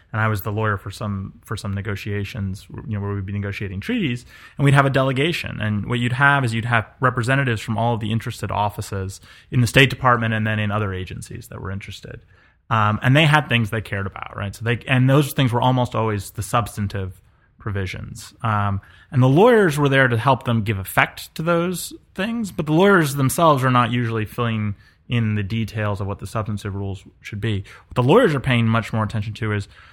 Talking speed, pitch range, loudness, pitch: 230 wpm, 100-125 Hz, -20 LUFS, 110 Hz